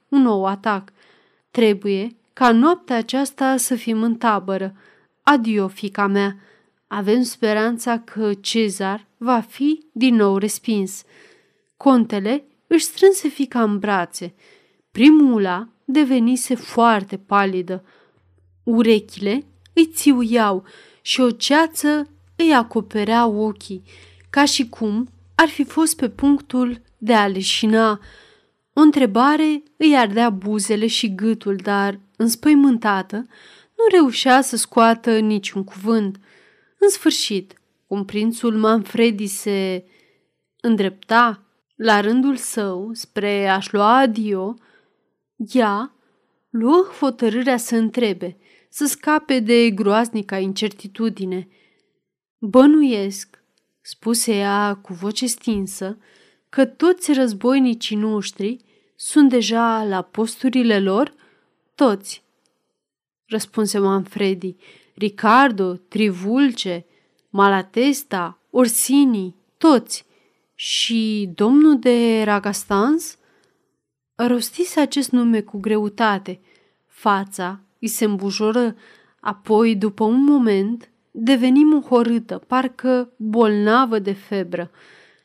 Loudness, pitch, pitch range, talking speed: -18 LUFS, 225 Hz, 205-260 Hz, 95 wpm